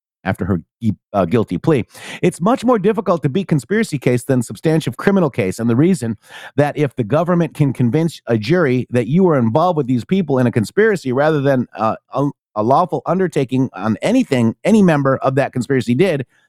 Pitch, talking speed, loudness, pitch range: 140 Hz, 195 wpm, -17 LUFS, 125-175 Hz